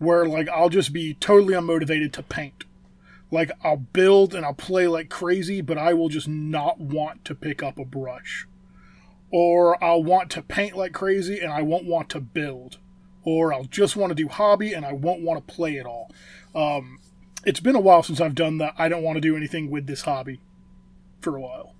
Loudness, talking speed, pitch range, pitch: -22 LUFS, 210 wpm, 145-175 Hz, 160 Hz